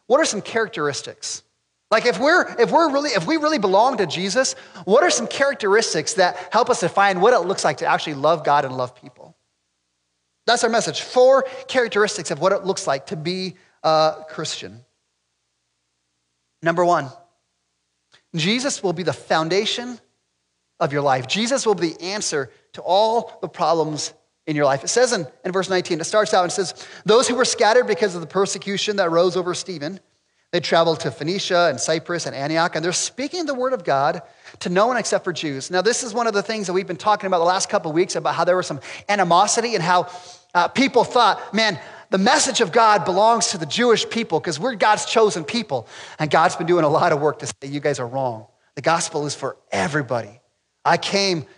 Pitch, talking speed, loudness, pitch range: 180 Hz, 210 wpm, -20 LUFS, 150-215 Hz